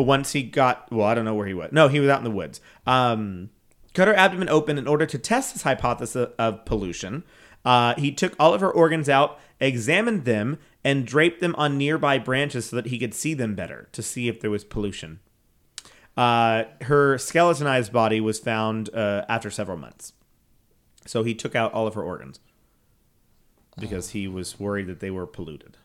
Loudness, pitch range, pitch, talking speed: -23 LUFS, 105-140 Hz, 120 Hz, 195 wpm